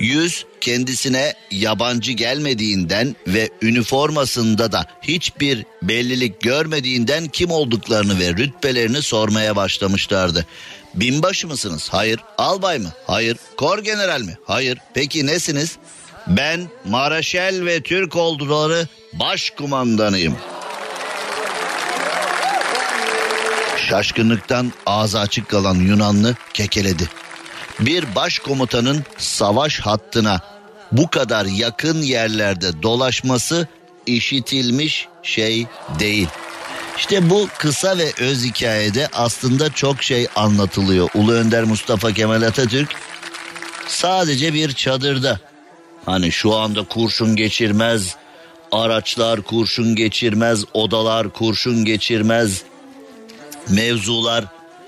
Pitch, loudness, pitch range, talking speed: 120 Hz, -18 LUFS, 110-145 Hz, 90 wpm